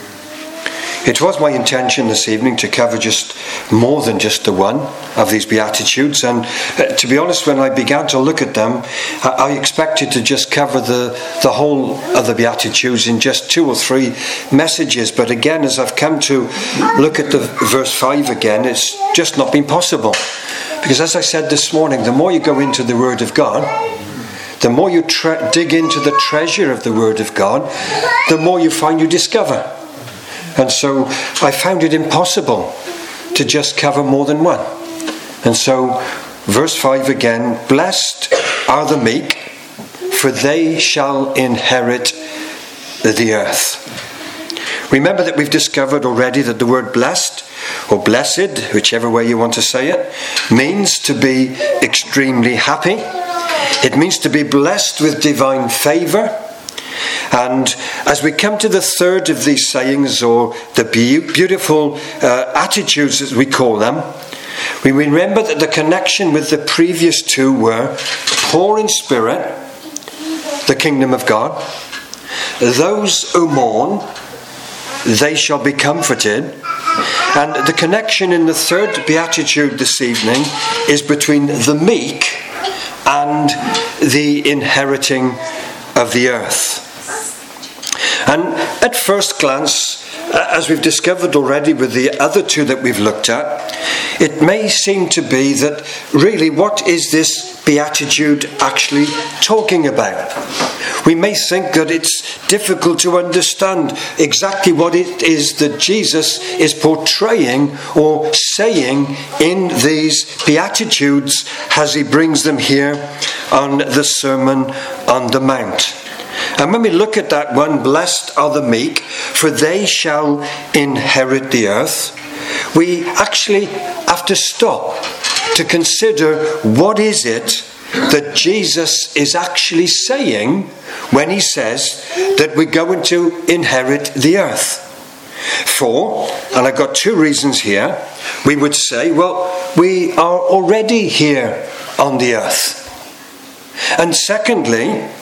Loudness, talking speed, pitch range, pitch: -13 LUFS, 140 wpm, 135-175 Hz, 150 Hz